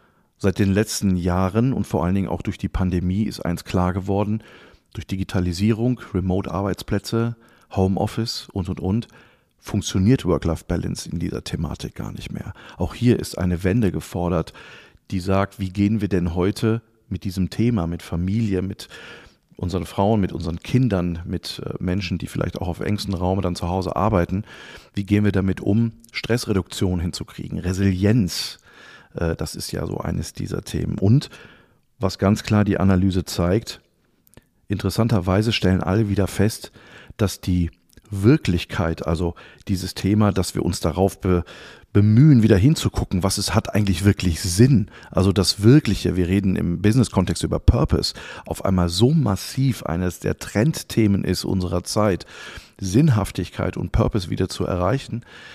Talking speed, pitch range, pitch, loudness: 150 wpm, 90-110 Hz, 95 Hz, -22 LUFS